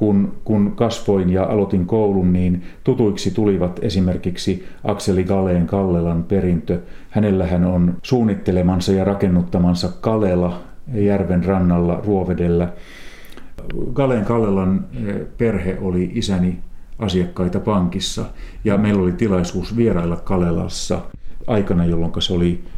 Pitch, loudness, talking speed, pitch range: 95 Hz, -19 LUFS, 110 wpm, 90-100 Hz